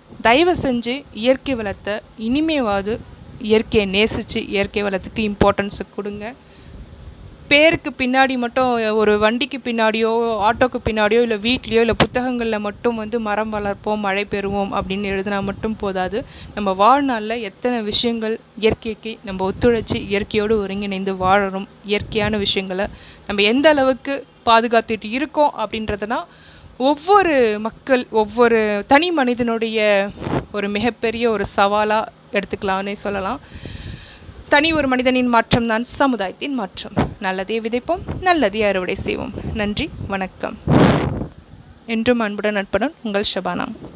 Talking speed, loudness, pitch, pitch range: 110 wpm, -19 LUFS, 220 Hz, 205-245 Hz